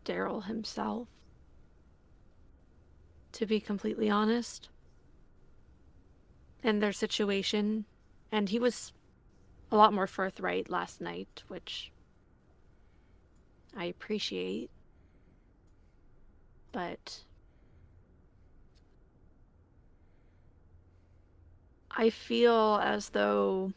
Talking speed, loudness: 65 wpm, -31 LUFS